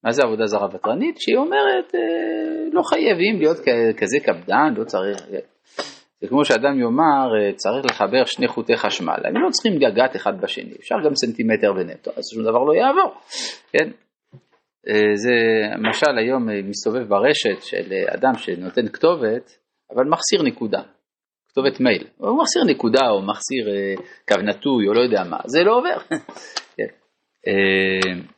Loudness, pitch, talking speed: -19 LUFS, 155 Hz, 150 wpm